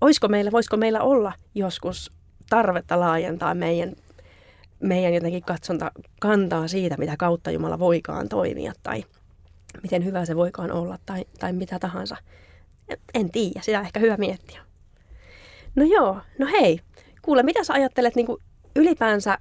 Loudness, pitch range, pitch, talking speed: -23 LUFS, 165-220 Hz, 180 Hz, 140 wpm